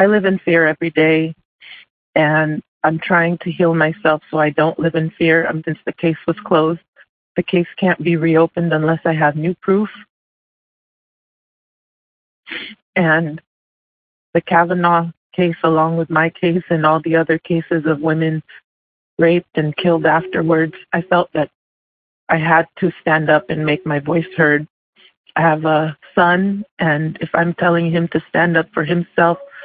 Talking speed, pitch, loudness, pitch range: 165 wpm, 165 Hz, -16 LUFS, 155-170 Hz